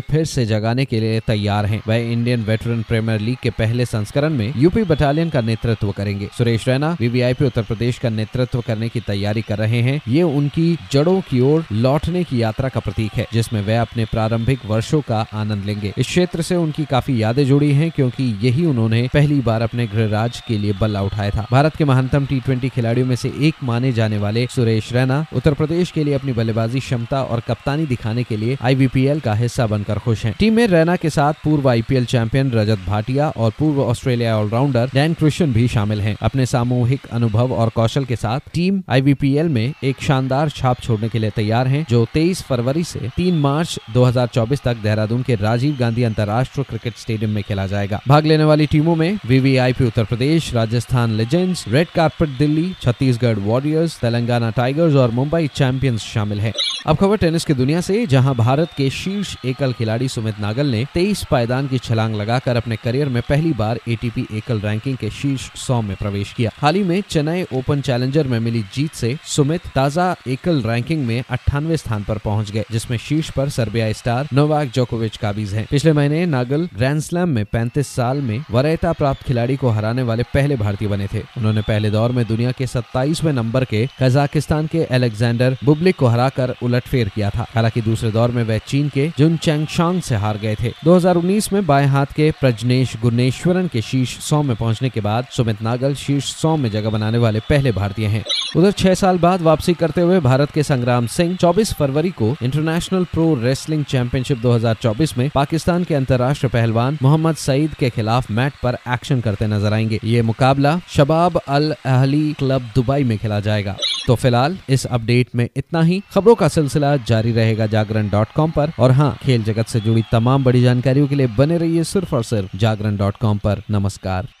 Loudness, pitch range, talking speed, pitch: -18 LUFS, 115-150 Hz, 190 wpm, 125 Hz